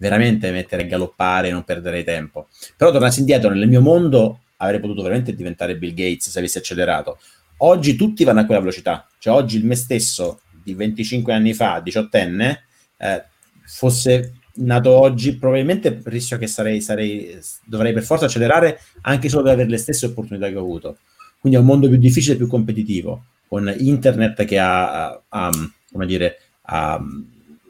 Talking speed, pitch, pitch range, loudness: 175 wpm, 110 Hz, 95-125 Hz, -17 LUFS